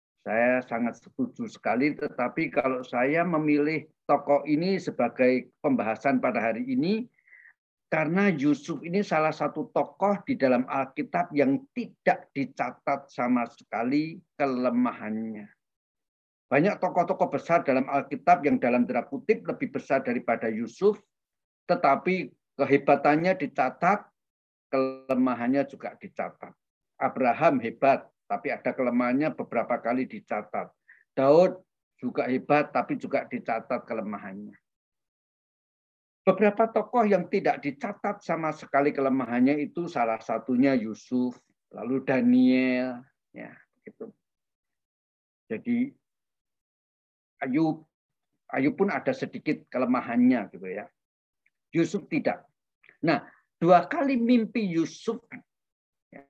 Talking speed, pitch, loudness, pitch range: 100 wpm, 145 Hz, -27 LUFS, 125-185 Hz